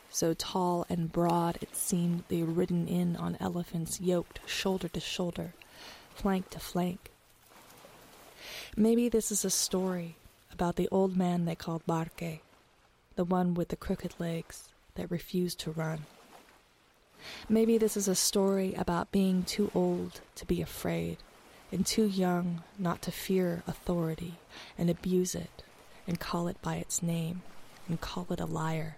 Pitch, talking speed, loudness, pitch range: 175 Hz, 155 wpm, -32 LUFS, 165-185 Hz